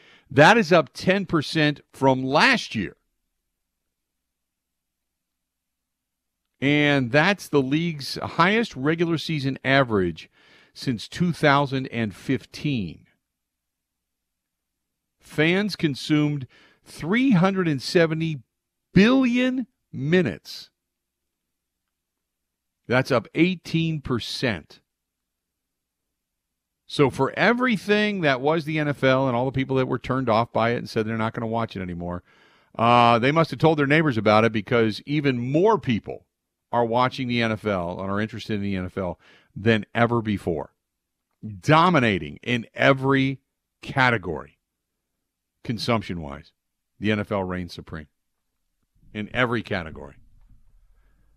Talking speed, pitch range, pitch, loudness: 105 wpm, 85-145 Hz, 115 Hz, -22 LUFS